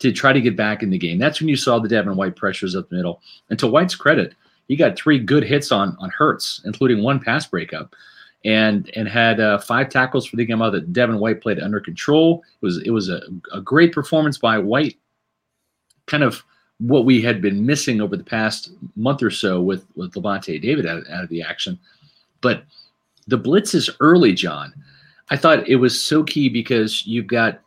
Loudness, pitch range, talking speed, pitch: -18 LUFS, 105-140 Hz, 210 wpm, 115 Hz